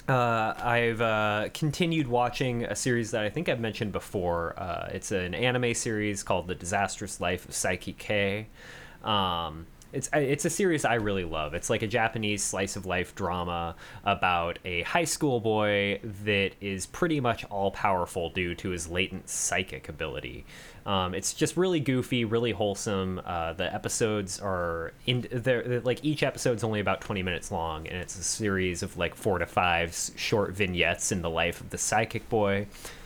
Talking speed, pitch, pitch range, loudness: 175 wpm, 105 Hz, 95-120 Hz, -29 LUFS